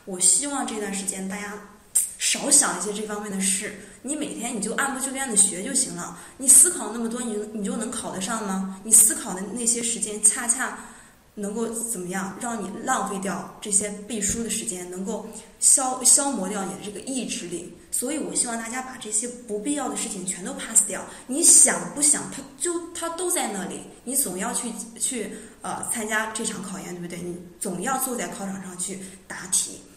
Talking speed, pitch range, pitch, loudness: 290 characters per minute, 195-245 Hz, 220 Hz, -22 LUFS